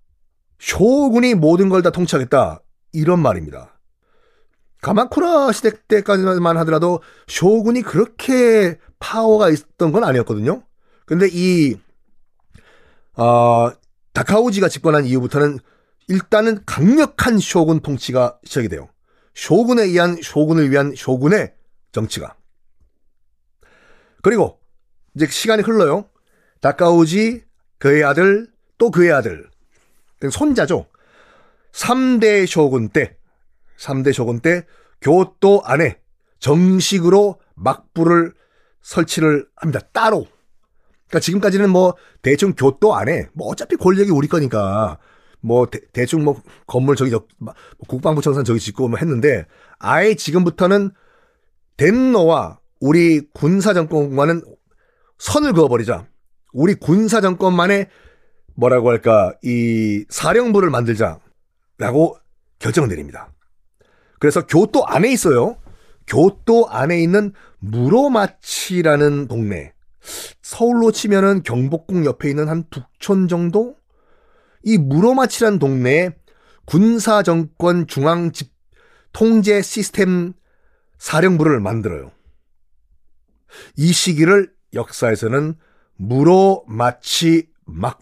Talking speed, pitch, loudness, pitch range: 235 characters per minute, 170 Hz, -16 LUFS, 135-205 Hz